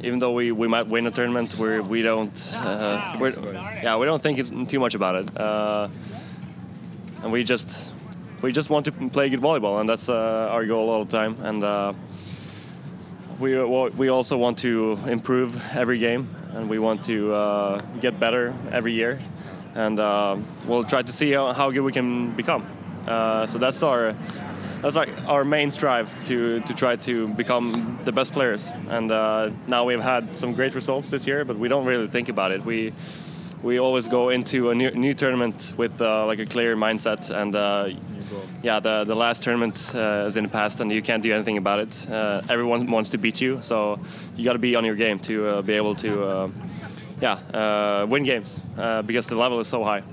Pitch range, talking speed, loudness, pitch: 110-125 Hz, 205 wpm, -23 LUFS, 115 Hz